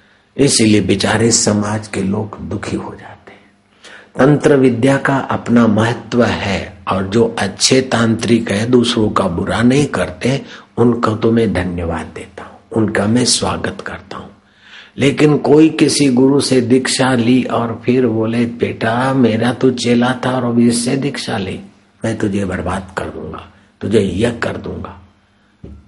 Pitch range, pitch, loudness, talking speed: 100-125 Hz, 115 Hz, -14 LUFS, 150 wpm